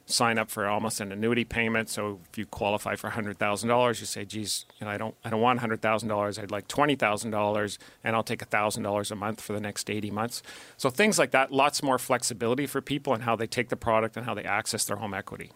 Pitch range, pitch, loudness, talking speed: 105-120 Hz, 110 Hz, -28 LUFS, 230 wpm